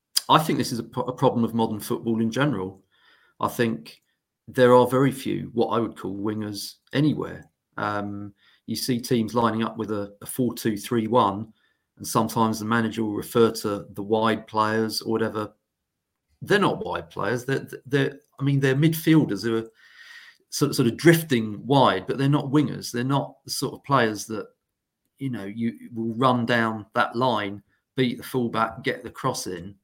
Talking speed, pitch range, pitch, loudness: 185 wpm, 110-130 Hz, 115 Hz, -24 LUFS